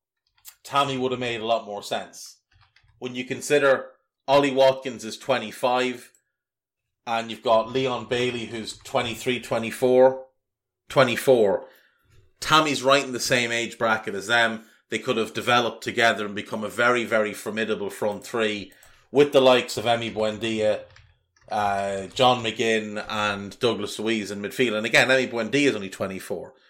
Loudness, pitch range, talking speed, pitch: -23 LUFS, 110-130 Hz, 150 wpm, 115 Hz